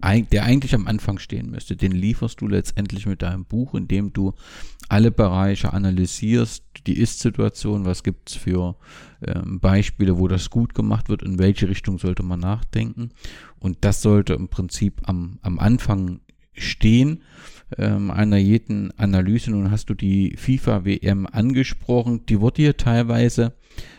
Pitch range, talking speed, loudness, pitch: 95-115 Hz, 155 wpm, -21 LUFS, 105 Hz